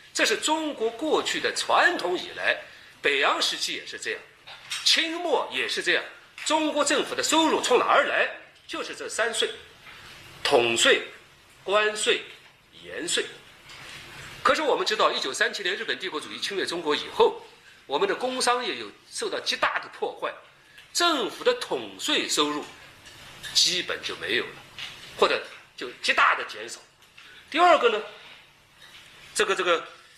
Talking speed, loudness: 225 characters per minute, -24 LUFS